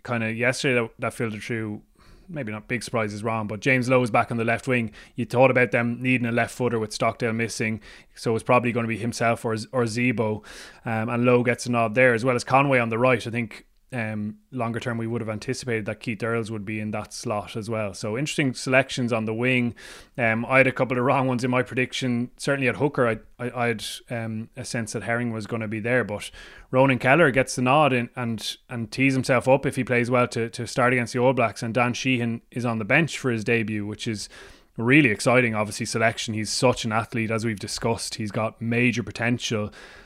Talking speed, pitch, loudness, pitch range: 240 wpm, 120 Hz, -24 LUFS, 115-125 Hz